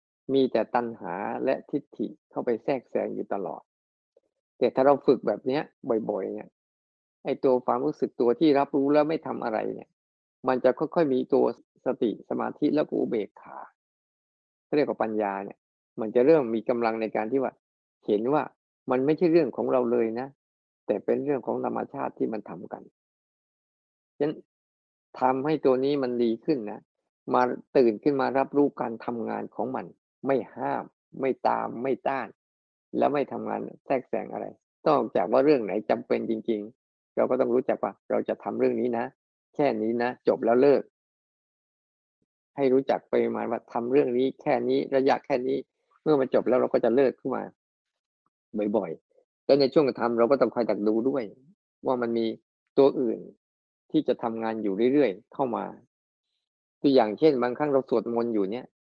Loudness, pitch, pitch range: -26 LUFS, 120 Hz, 110-135 Hz